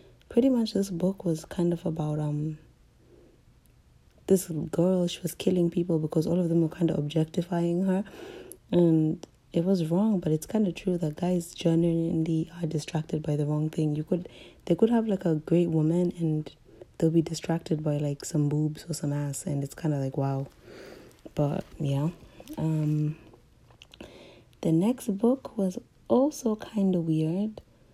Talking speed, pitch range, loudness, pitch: 170 wpm, 155-180 Hz, -28 LUFS, 165 Hz